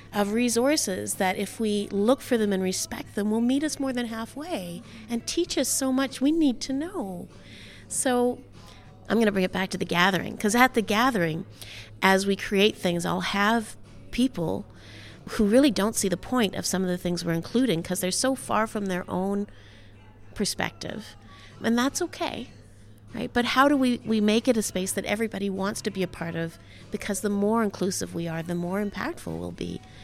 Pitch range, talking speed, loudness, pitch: 175-240 Hz, 200 wpm, -26 LUFS, 205 Hz